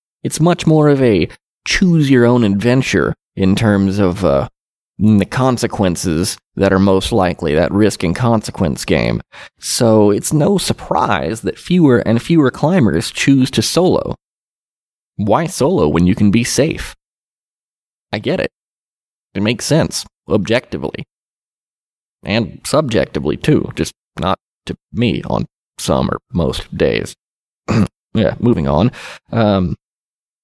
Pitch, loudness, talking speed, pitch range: 110 Hz, -15 LUFS, 130 wpm, 95-130 Hz